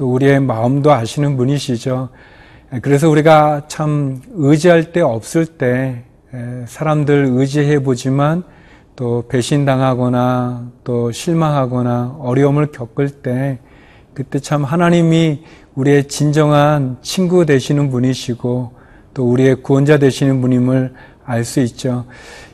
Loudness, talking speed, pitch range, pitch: -15 LUFS, 255 characters per minute, 125-150 Hz, 135 Hz